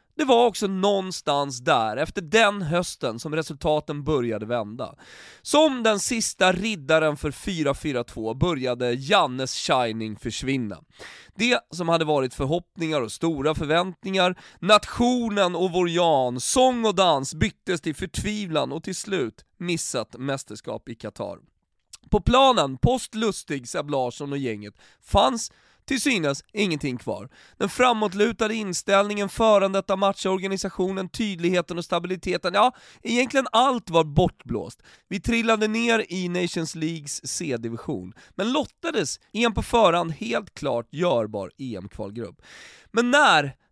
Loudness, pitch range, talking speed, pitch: -23 LUFS, 140-210 Hz, 125 wpm, 175 Hz